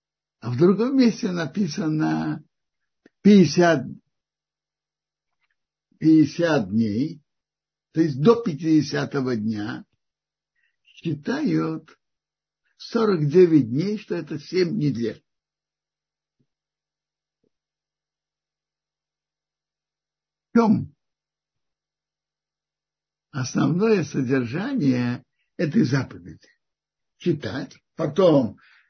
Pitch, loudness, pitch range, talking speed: 155 Hz, -22 LUFS, 130-185 Hz, 60 wpm